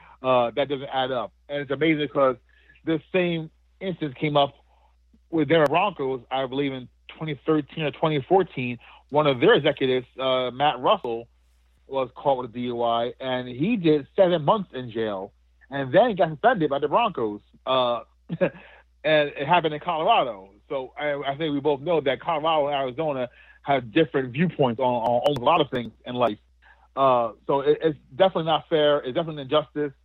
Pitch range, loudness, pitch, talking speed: 125-155 Hz, -24 LUFS, 140 Hz, 175 wpm